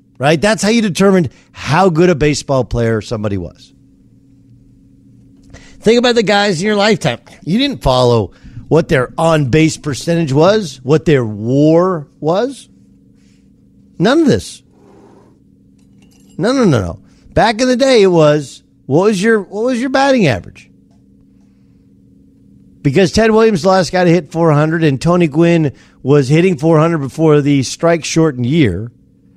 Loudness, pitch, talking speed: -13 LUFS, 150 Hz, 145 wpm